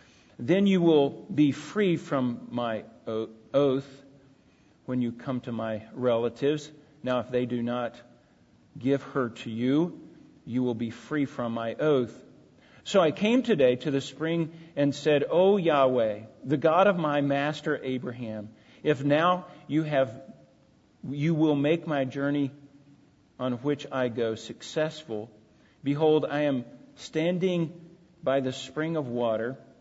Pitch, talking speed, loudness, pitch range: 140 Hz, 140 wpm, -27 LUFS, 120-155 Hz